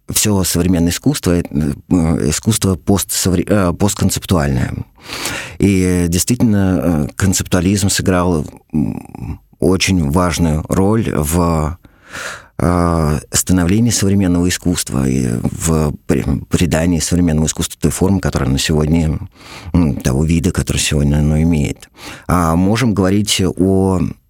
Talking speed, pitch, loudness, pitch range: 90 wpm, 90 Hz, -15 LUFS, 80-95 Hz